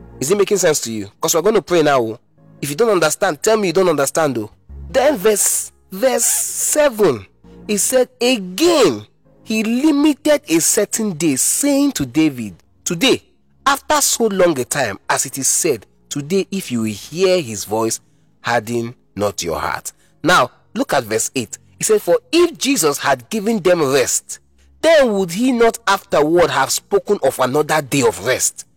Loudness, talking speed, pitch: -16 LUFS, 175 wpm, 180 Hz